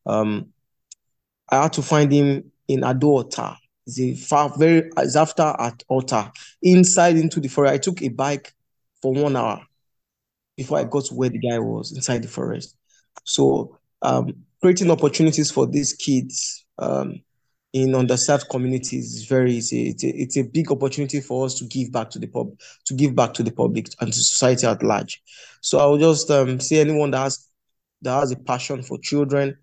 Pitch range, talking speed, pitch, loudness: 125-145 Hz, 185 wpm, 135 Hz, -20 LUFS